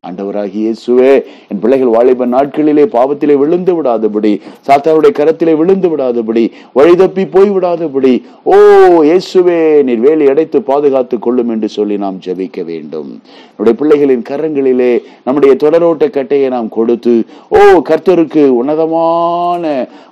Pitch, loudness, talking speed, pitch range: 140 Hz, -10 LUFS, 115 wpm, 120-165 Hz